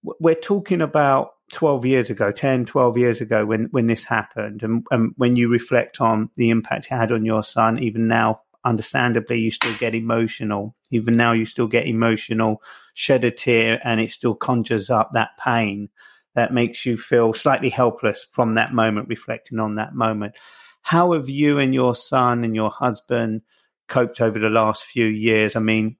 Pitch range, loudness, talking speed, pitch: 110-125 Hz, -20 LUFS, 185 wpm, 115 Hz